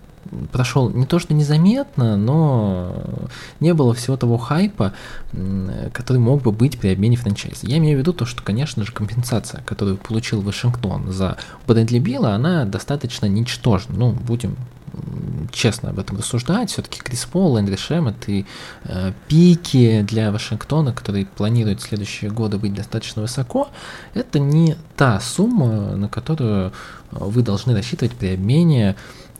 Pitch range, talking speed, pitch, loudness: 105-140 Hz, 145 wpm, 120 Hz, -19 LUFS